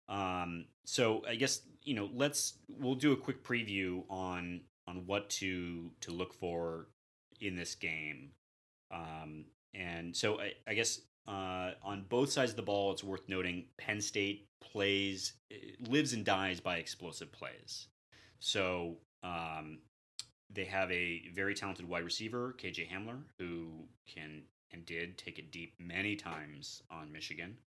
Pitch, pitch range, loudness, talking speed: 90 Hz, 85-100 Hz, -38 LUFS, 150 wpm